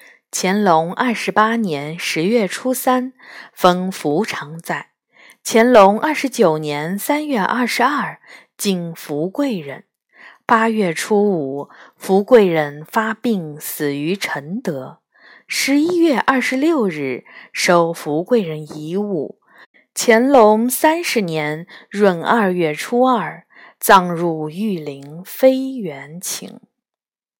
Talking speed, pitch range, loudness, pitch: 160 characters per minute, 165-240 Hz, -17 LUFS, 200 Hz